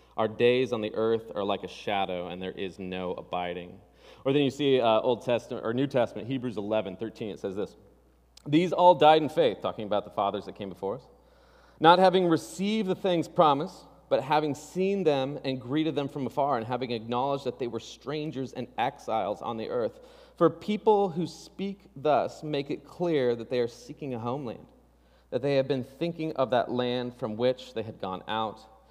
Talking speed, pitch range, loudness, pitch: 200 wpm, 110-160 Hz, -28 LUFS, 130 Hz